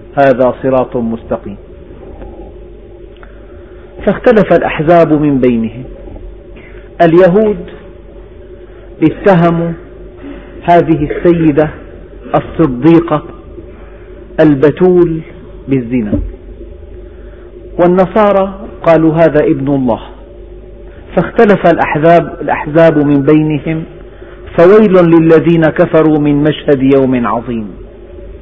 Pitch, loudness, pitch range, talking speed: 160 Hz, -10 LUFS, 140-170 Hz, 65 wpm